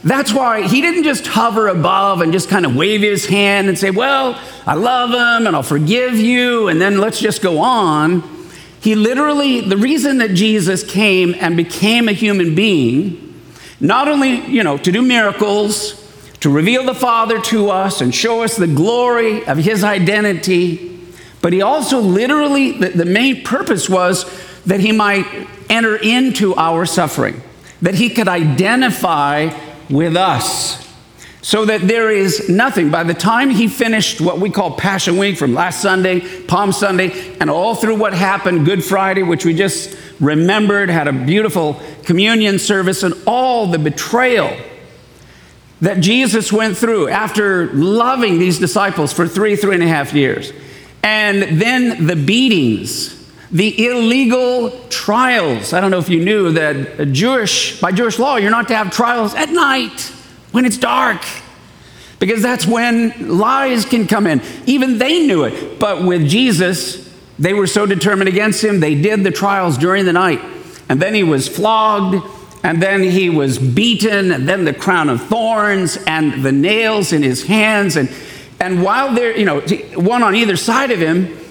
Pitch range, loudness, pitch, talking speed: 175-230 Hz, -14 LUFS, 200 Hz, 170 wpm